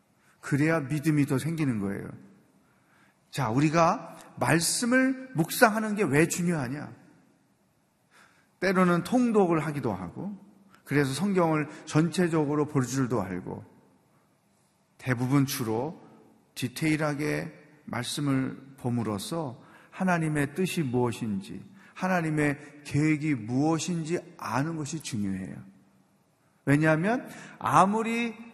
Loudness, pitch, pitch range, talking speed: -27 LUFS, 155 Hz, 135-175 Hz, 230 characters per minute